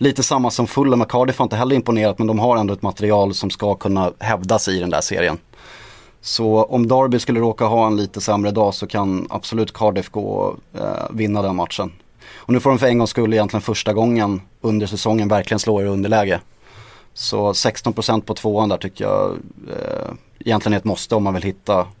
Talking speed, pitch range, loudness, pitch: 215 wpm, 100-115 Hz, -19 LUFS, 110 Hz